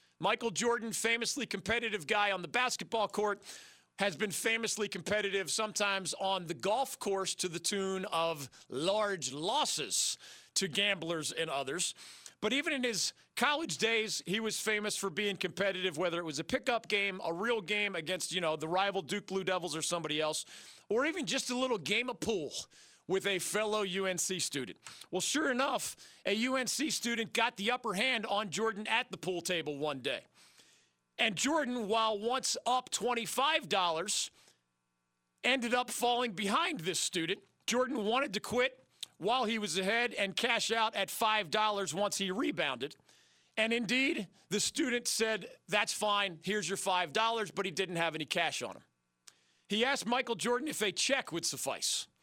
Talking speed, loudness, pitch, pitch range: 170 wpm, -33 LUFS, 205 Hz, 185-230 Hz